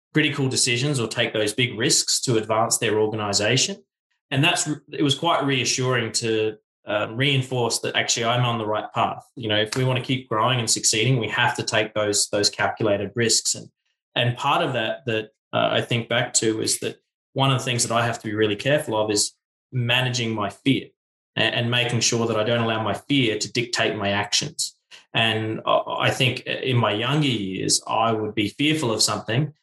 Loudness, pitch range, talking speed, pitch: -22 LUFS, 110-130 Hz, 205 wpm, 115 Hz